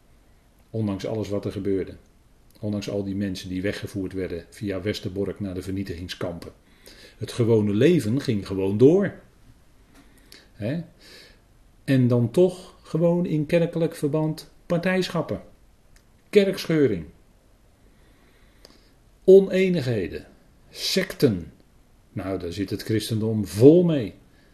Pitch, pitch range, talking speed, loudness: 105 Hz, 95-150 Hz, 100 wpm, -23 LUFS